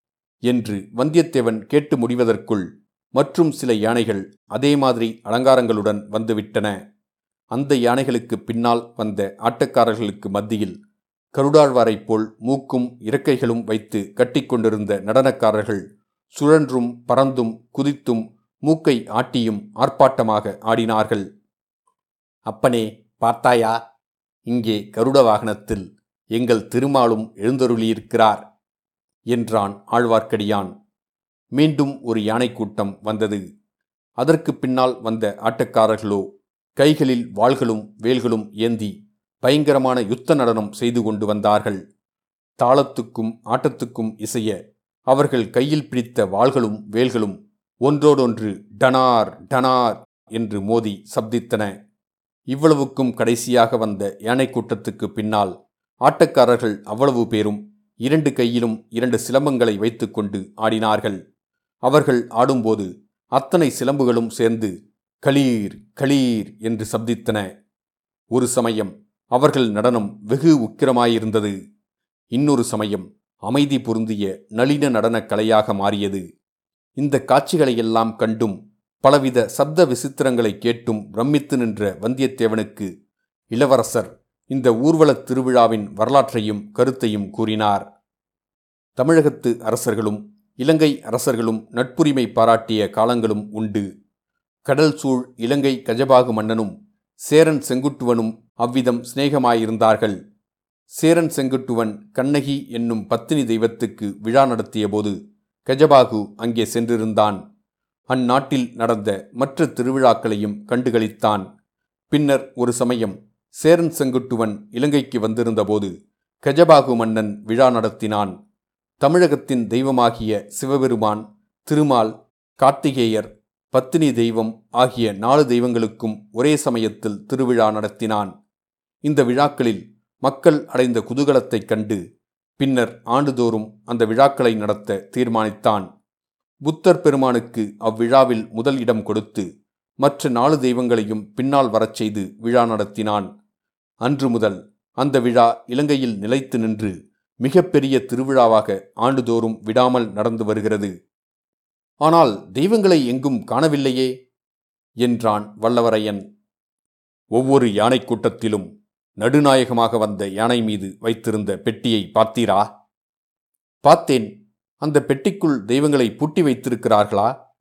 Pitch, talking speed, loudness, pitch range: 115 Hz, 90 wpm, -19 LUFS, 110-135 Hz